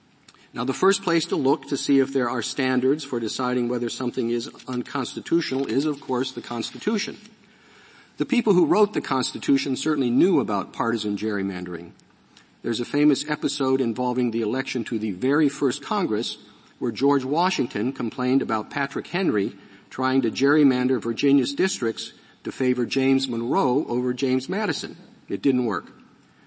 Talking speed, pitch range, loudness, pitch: 155 wpm, 120-140 Hz, -24 LUFS, 130 Hz